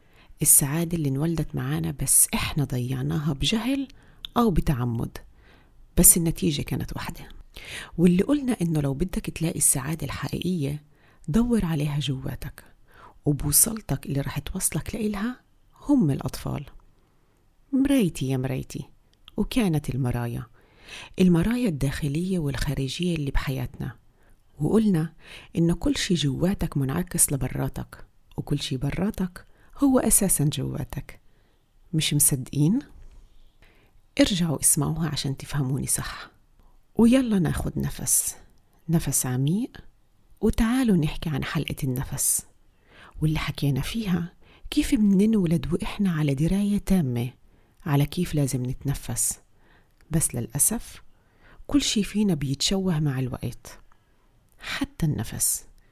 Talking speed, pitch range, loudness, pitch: 100 wpm, 135-185 Hz, -24 LUFS, 150 Hz